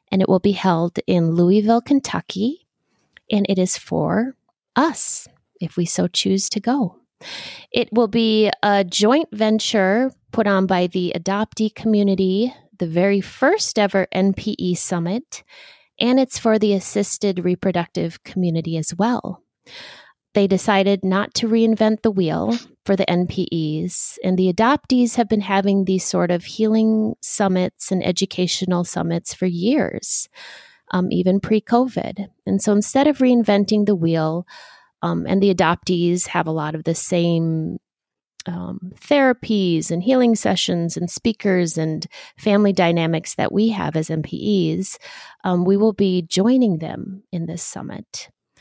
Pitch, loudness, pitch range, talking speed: 195 Hz, -19 LUFS, 180-220 Hz, 145 wpm